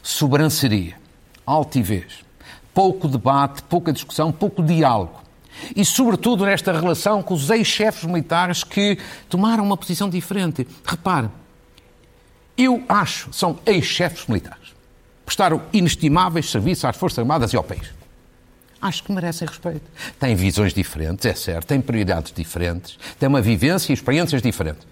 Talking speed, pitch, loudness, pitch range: 130 wpm, 150 Hz, -20 LUFS, 115-180 Hz